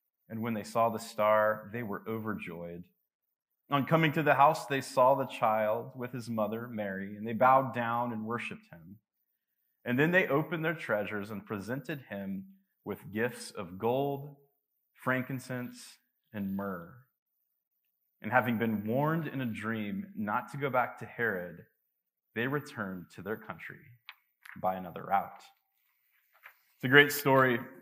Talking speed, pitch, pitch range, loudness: 150 wpm, 120 Hz, 105-135 Hz, -31 LUFS